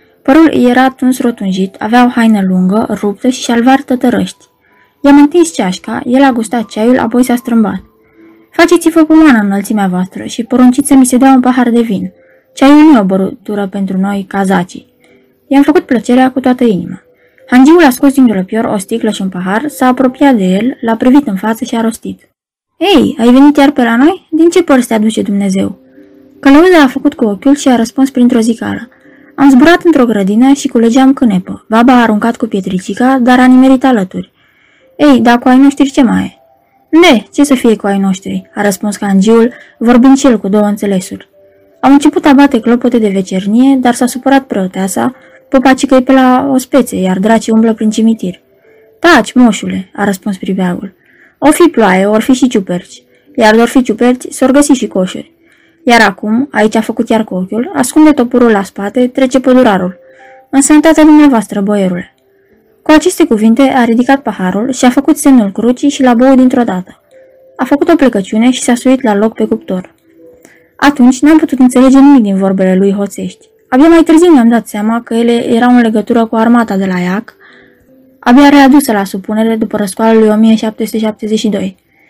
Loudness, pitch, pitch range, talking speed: -8 LUFS, 240 Hz, 210-270 Hz, 185 wpm